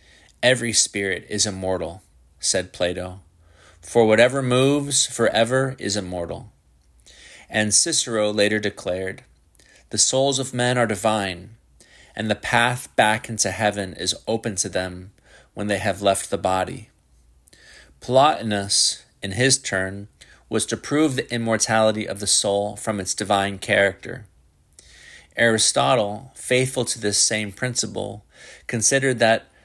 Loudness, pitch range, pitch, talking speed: -21 LUFS, 95-120 Hz, 105 Hz, 125 wpm